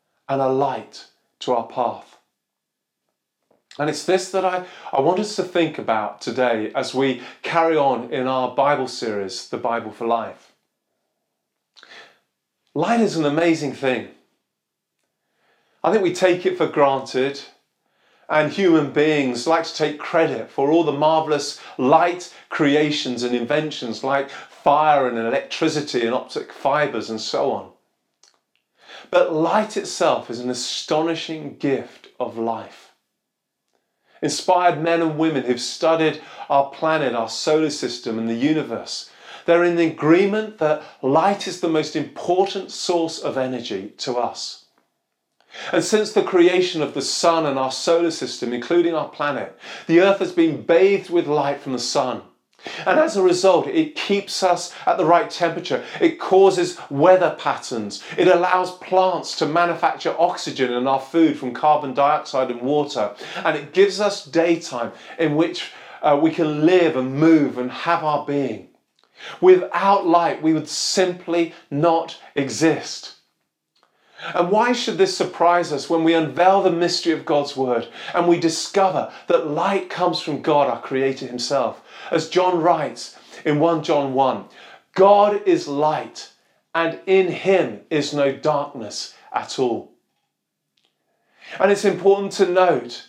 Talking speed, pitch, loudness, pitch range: 150 wpm, 160 Hz, -20 LUFS, 140-175 Hz